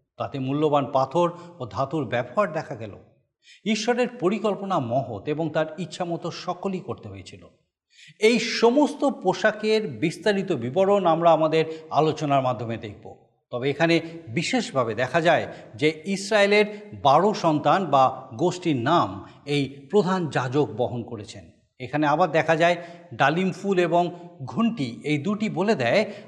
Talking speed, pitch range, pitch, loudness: 130 wpm, 135-195 Hz, 165 Hz, -23 LUFS